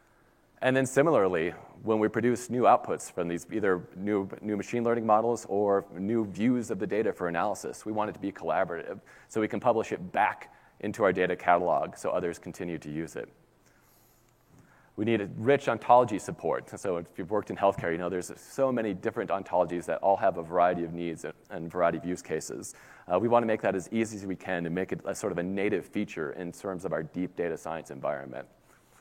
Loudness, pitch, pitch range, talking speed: -29 LUFS, 100 Hz, 90-115 Hz, 215 wpm